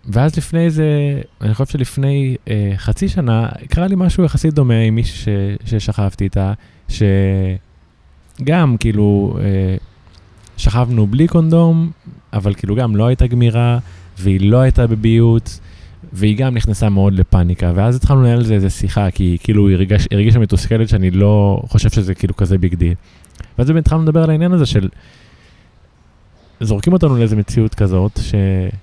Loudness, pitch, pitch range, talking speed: -14 LUFS, 105 Hz, 95-125 Hz, 150 wpm